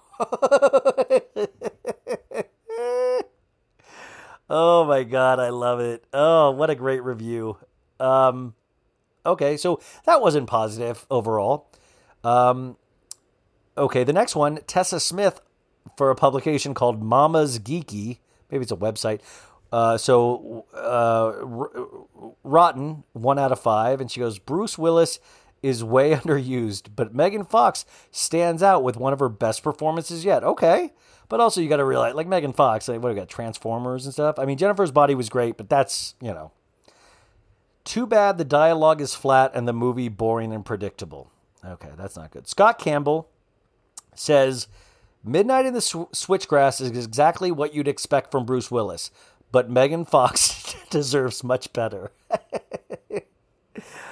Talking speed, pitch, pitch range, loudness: 140 wpm, 135 Hz, 120-165 Hz, -22 LUFS